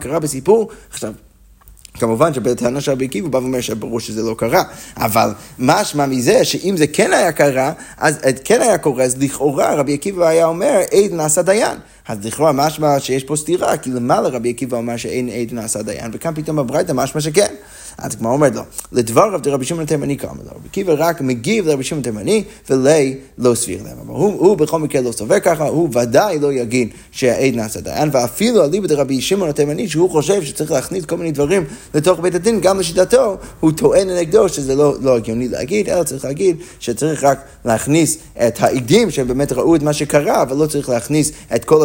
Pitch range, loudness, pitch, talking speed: 125-165 Hz, -16 LUFS, 145 Hz, 175 wpm